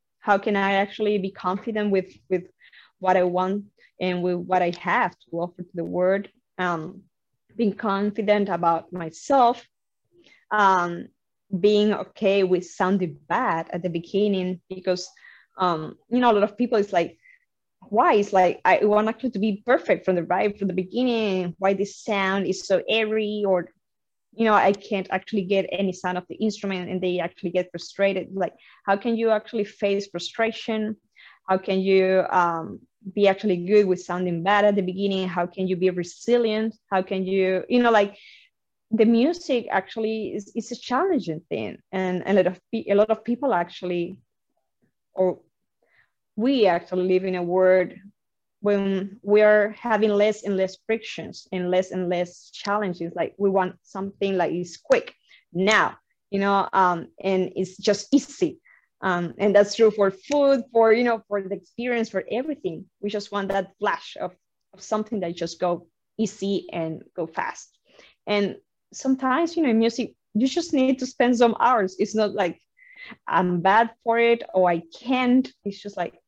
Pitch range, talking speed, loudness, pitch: 185-220 Hz, 175 wpm, -23 LUFS, 195 Hz